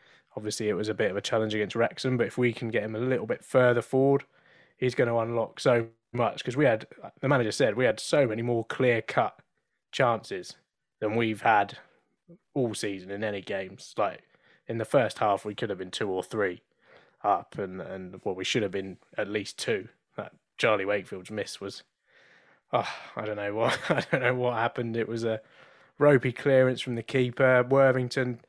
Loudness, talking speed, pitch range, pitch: -28 LUFS, 205 wpm, 110-130 Hz, 120 Hz